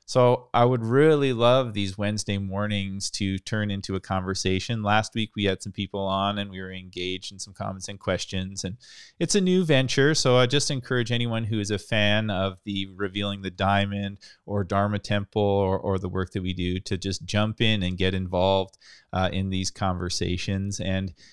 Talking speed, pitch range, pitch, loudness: 195 wpm, 95-110 Hz, 100 Hz, -25 LUFS